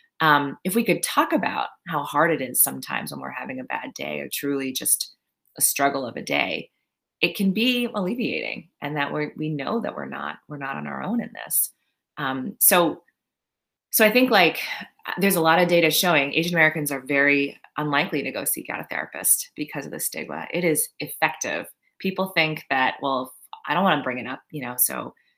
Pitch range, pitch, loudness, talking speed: 140-185 Hz, 150 Hz, -23 LUFS, 210 wpm